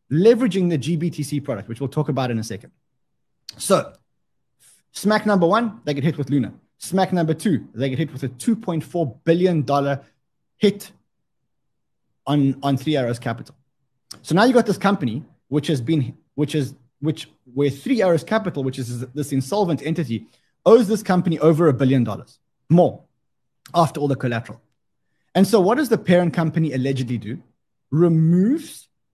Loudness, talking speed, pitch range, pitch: -20 LUFS, 165 wpm, 135-175 Hz, 150 Hz